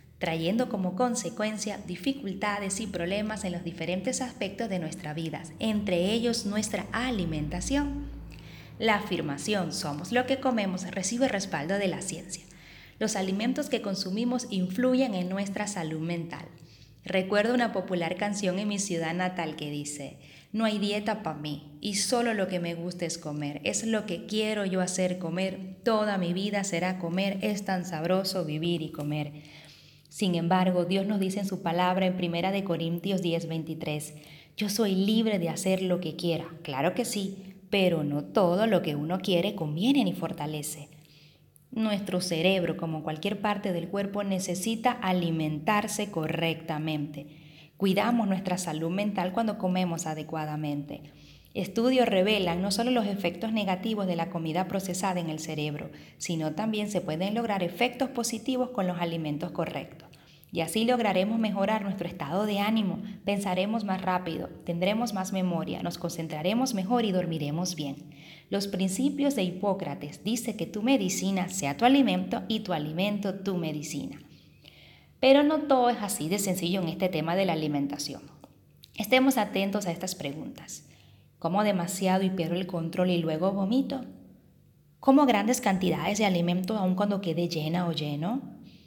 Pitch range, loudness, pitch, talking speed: 165-210 Hz, -29 LUFS, 185 Hz, 155 wpm